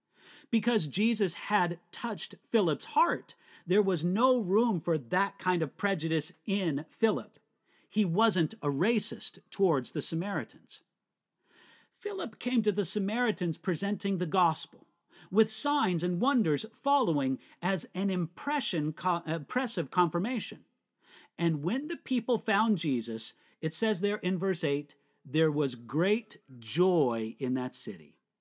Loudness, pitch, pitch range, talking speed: -30 LUFS, 190 Hz, 160-220 Hz, 130 wpm